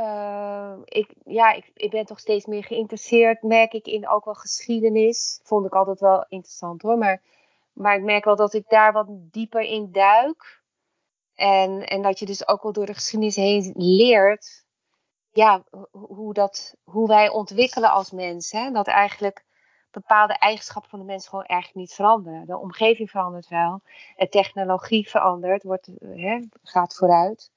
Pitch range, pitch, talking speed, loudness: 195-220 Hz, 205 Hz, 170 wpm, -21 LUFS